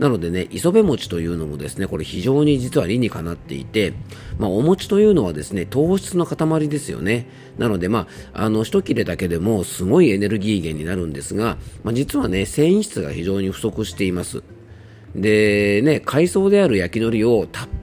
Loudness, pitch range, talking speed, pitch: -19 LUFS, 95-140 Hz, 385 characters per minute, 110 Hz